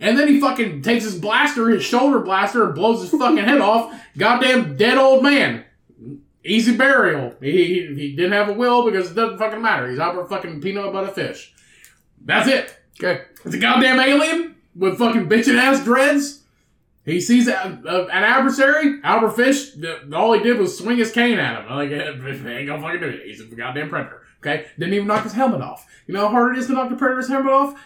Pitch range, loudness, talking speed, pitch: 195-260 Hz, -18 LUFS, 215 wpm, 230 Hz